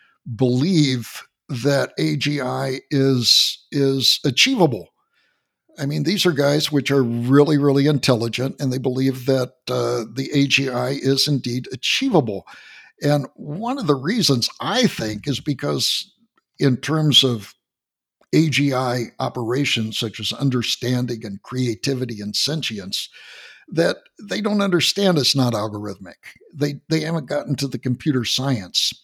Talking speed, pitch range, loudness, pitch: 130 wpm, 125-145 Hz, -20 LUFS, 135 Hz